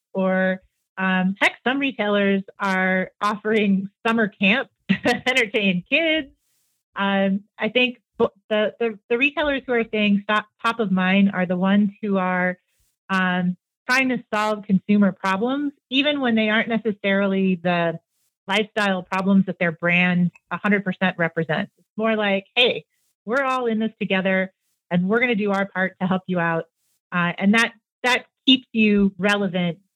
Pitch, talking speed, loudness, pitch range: 200 Hz, 155 wpm, -21 LUFS, 185-230 Hz